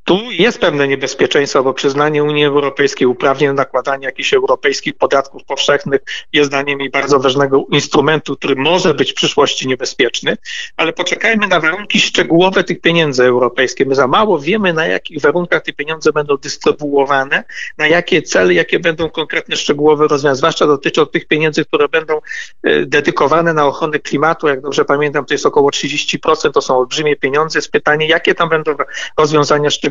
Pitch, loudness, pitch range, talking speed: 150 Hz, -13 LUFS, 140-160 Hz, 165 wpm